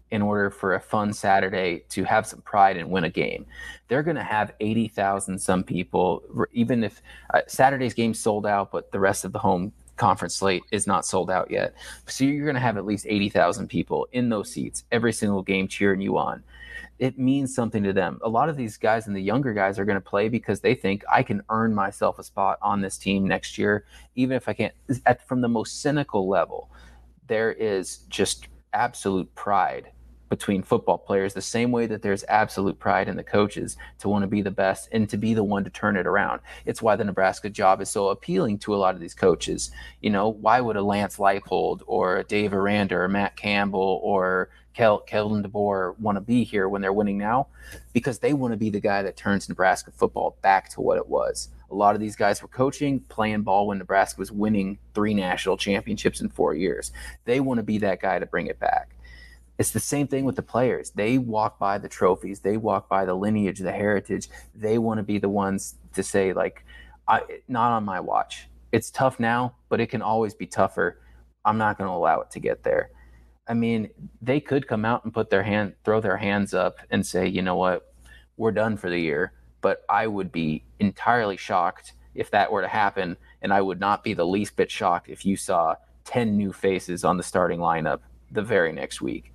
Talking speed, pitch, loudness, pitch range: 220 wpm, 100 Hz, -24 LUFS, 95-110 Hz